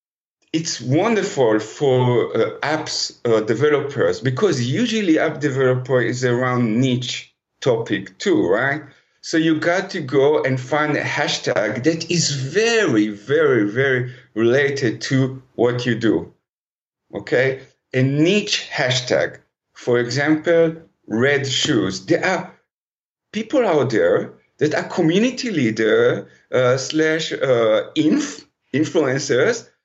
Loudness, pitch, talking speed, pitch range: -19 LUFS, 150 Hz, 115 wpm, 125-210 Hz